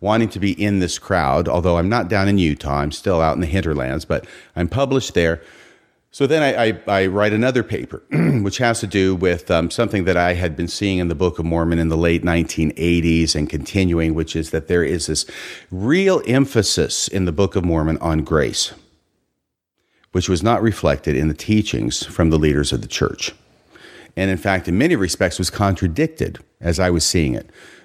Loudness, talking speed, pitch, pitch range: -19 LUFS, 205 wpm, 90 Hz, 80-100 Hz